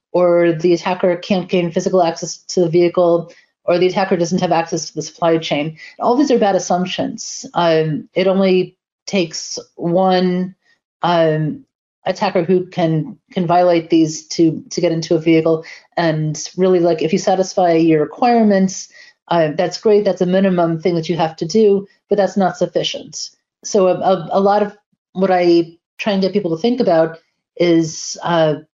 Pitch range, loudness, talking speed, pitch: 165-190 Hz, -16 LUFS, 175 wpm, 180 Hz